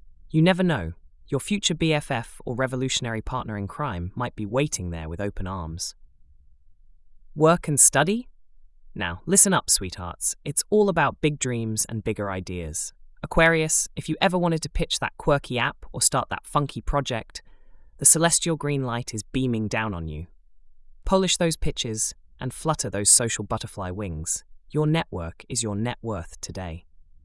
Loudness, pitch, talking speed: -23 LUFS, 115 Hz, 165 wpm